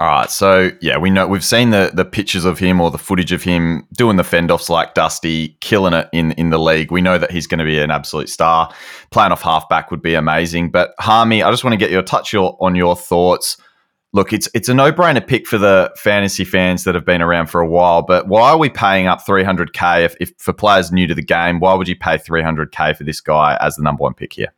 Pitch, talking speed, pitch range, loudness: 90 Hz, 265 wpm, 80-95 Hz, -14 LUFS